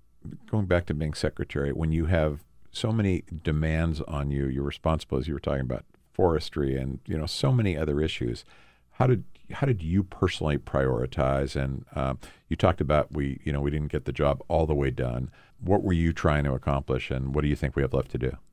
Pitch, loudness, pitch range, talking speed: 75 Hz, -28 LUFS, 70-80 Hz, 220 wpm